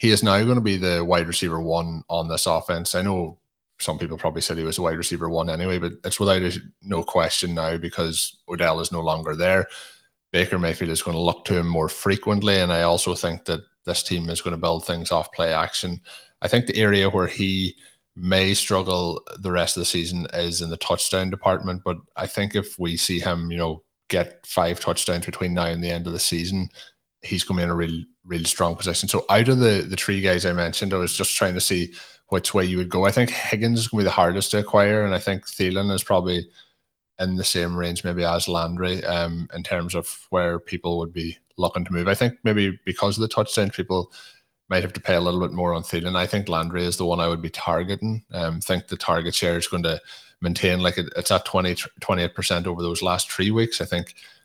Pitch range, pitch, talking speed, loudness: 85-95 Hz, 90 Hz, 240 wpm, -23 LUFS